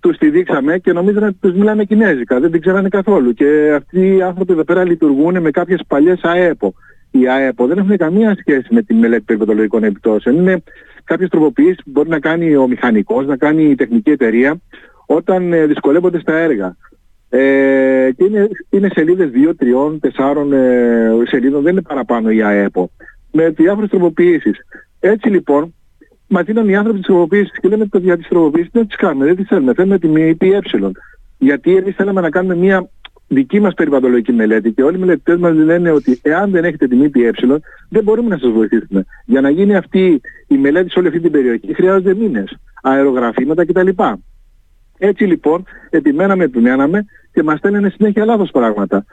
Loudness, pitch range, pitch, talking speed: -13 LUFS, 135-200 Hz, 170 Hz, 175 wpm